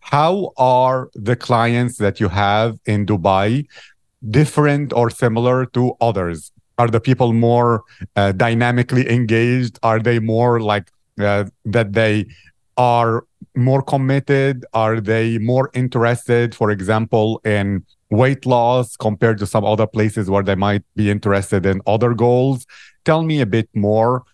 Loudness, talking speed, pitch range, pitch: -17 LUFS, 145 wpm, 105-125 Hz, 115 Hz